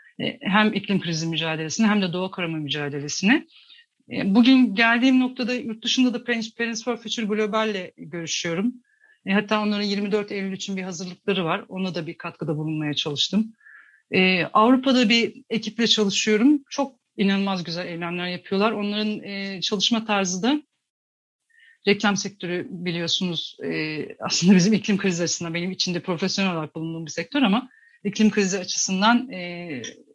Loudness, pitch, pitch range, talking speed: -23 LUFS, 200 Hz, 180-230 Hz, 130 wpm